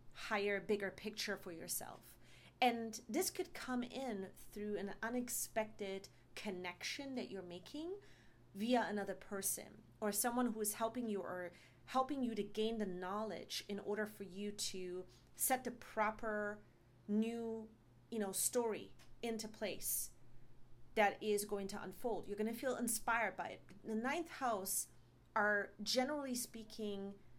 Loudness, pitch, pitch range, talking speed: -41 LUFS, 210 Hz, 195-230 Hz, 140 wpm